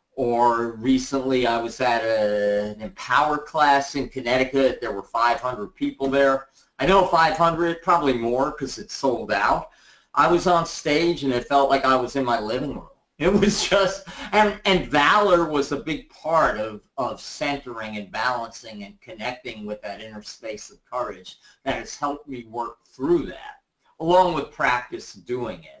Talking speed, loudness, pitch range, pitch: 170 wpm, -22 LUFS, 120-170 Hz, 135 Hz